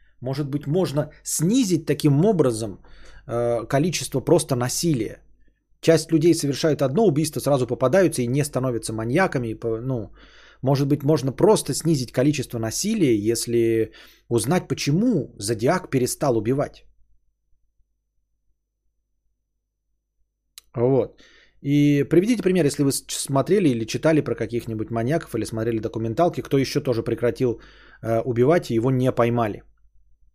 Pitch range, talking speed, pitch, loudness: 115-155 Hz, 115 wpm, 130 Hz, -22 LUFS